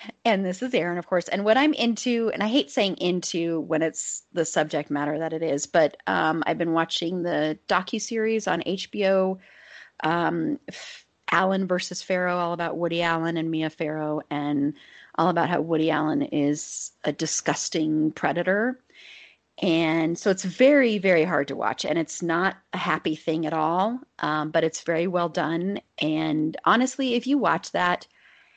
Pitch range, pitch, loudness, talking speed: 155-195 Hz, 170 Hz, -25 LUFS, 175 wpm